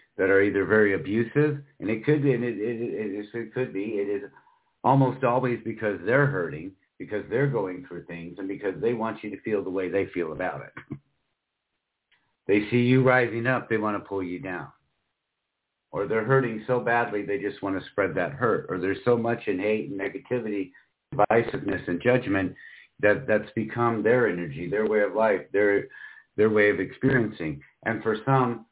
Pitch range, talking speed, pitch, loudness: 100-125 Hz, 195 wpm, 110 Hz, -26 LUFS